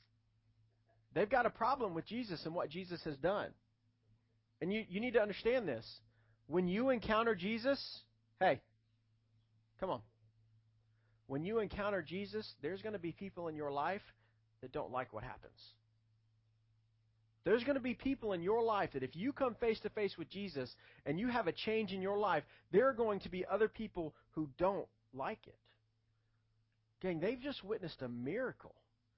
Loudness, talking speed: -39 LUFS, 175 wpm